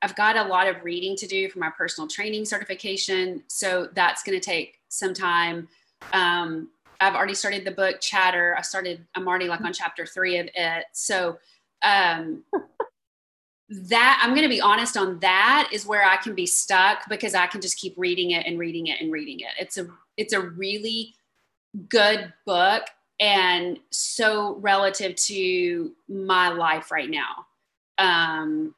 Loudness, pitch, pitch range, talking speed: -23 LUFS, 190 Hz, 175-210 Hz, 170 wpm